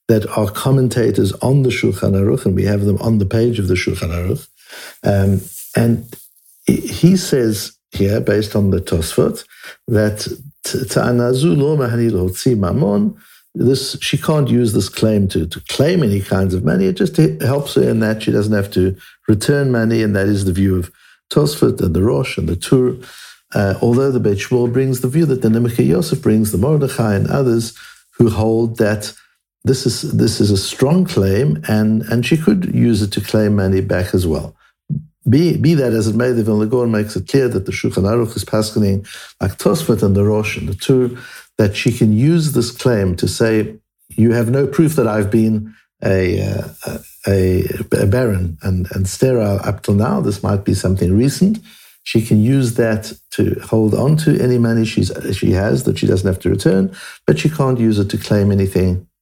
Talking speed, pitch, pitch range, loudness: 190 wpm, 110 Hz, 100-125 Hz, -16 LUFS